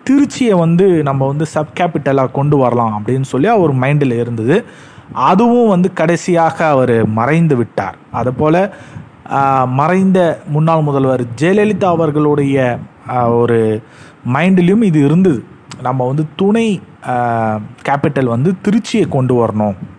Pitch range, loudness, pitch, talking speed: 125-175 Hz, -13 LUFS, 145 Hz, 115 wpm